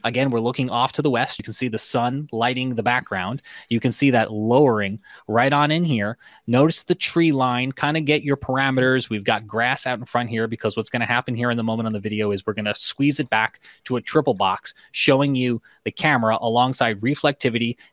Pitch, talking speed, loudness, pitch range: 120 Hz, 230 wpm, -21 LUFS, 110-135 Hz